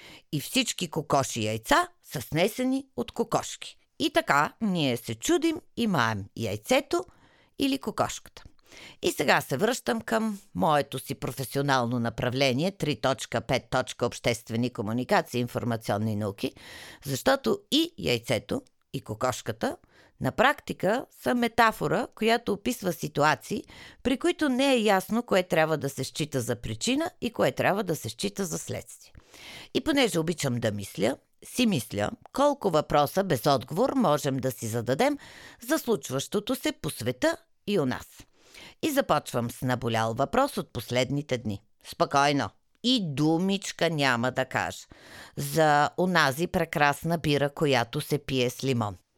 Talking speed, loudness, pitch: 135 wpm, -27 LUFS, 150 Hz